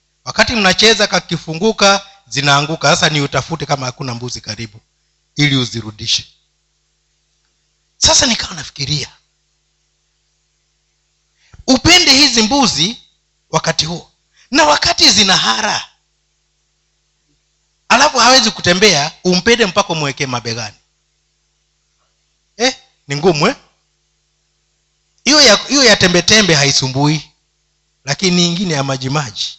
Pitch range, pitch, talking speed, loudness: 140-210 Hz, 165 Hz, 95 wpm, -12 LUFS